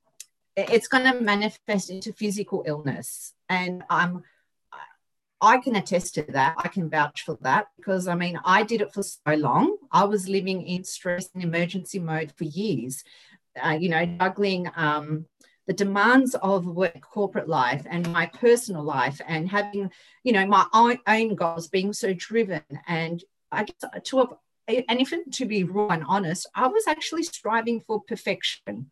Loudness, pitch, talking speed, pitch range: -24 LUFS, 190 Hz, 170 wpm, 170-215 Hz